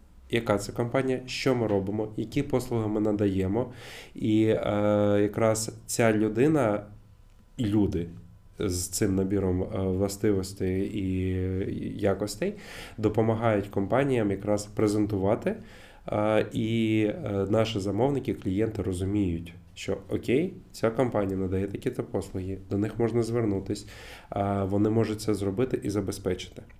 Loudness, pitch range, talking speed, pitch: -28 LUFS, 95-110 Hz, 105 wpm, 105 Hz